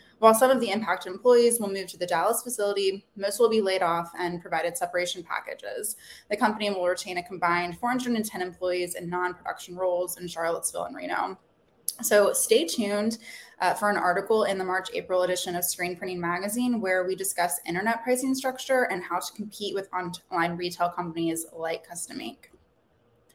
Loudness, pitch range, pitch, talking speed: -27 LUFS, 175-215 Hz, 185 Hz, 180 wpm